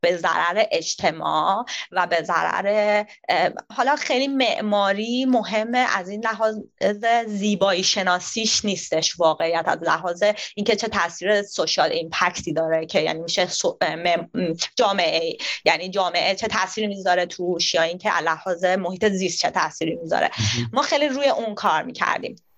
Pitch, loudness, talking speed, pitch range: 200 Hz, -22 LUFS, 135 wpm, 175-220 Hz